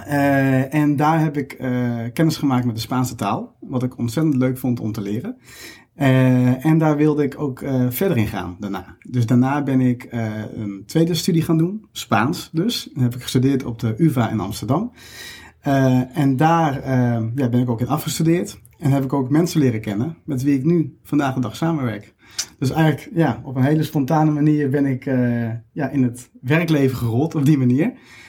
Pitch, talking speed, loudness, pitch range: 130 Hz, 205 wpm, -20 LUFS, 120-150 Hz